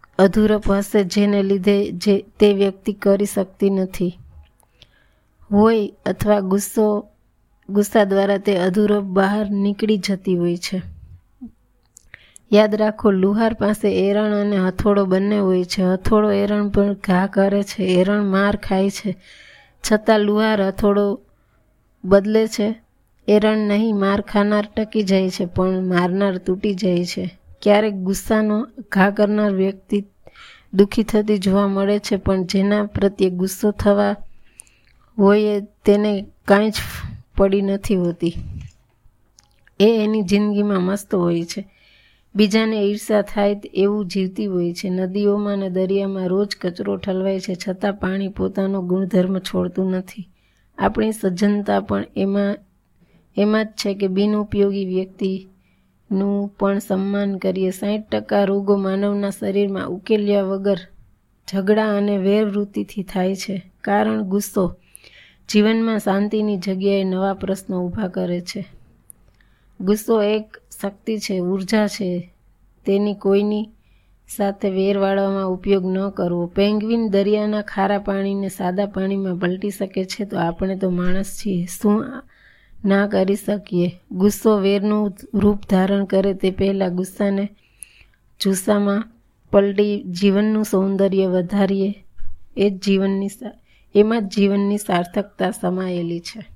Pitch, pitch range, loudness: 200 Hz, 190-205 Hz, -19 LUFS